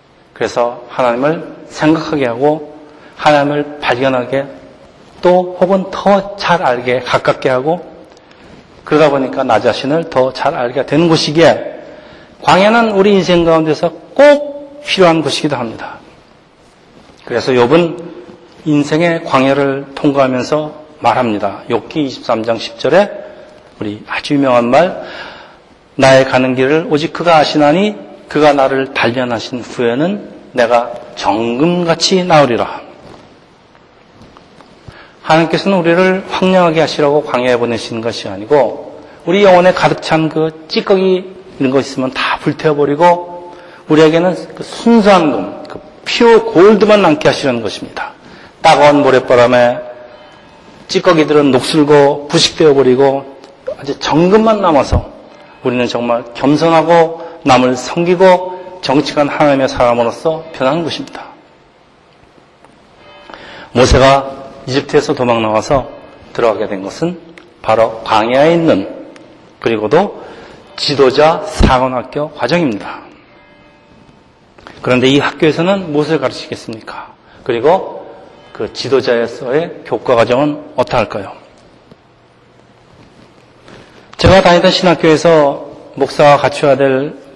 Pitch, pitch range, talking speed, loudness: 150 Hz, 130-170 Hz, 265 characters per minute, -12 LUFS